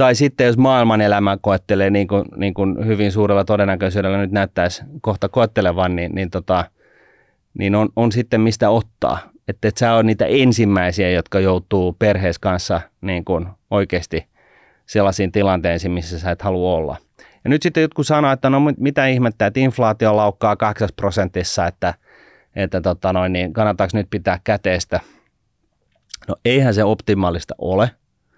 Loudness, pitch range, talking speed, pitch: -18 LUFS, 95-110 Hz, 160 wpm, 100 Hz